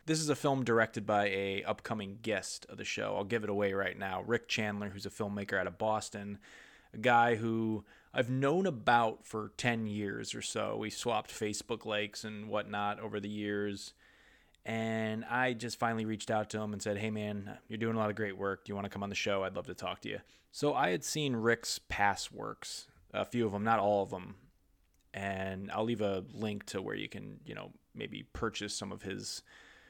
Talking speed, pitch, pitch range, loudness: 220 wpm, 105 Hz, 100-115 Hz, -35 LUFS